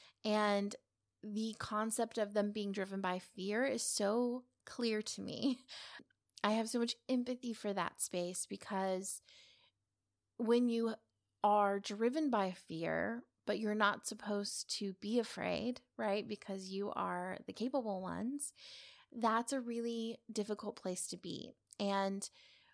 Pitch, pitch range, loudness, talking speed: 210 Hz, 195-235 Hz, -38 LUFS, 135 wpm